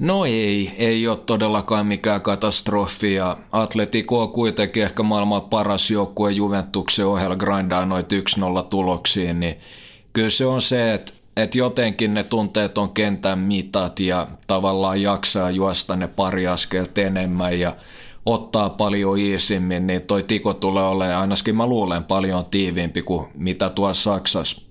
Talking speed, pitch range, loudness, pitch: 145 wpm, 95-110 Hz, -21 LUFS, 100 Hz